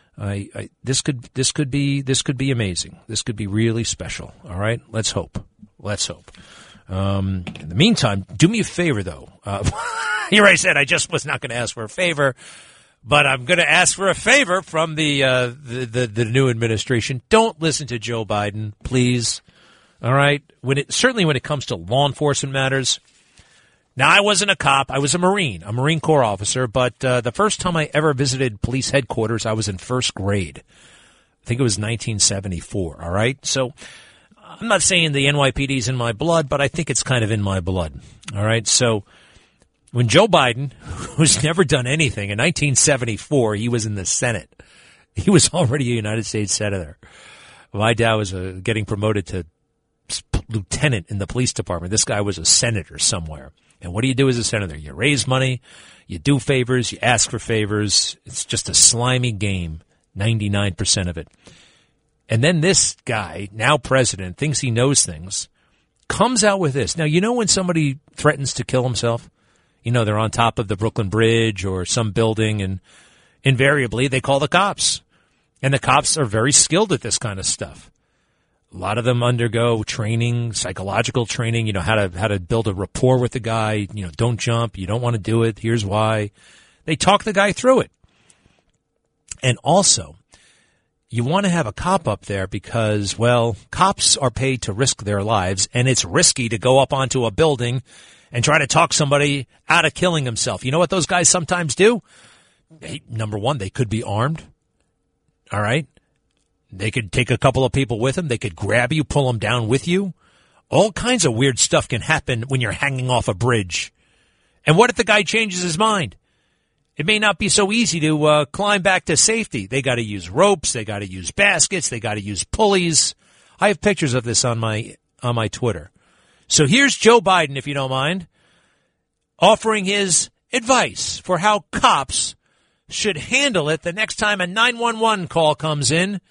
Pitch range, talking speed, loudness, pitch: 110-155 Hz, 195 wpm, -18 LUFS, 125 Hz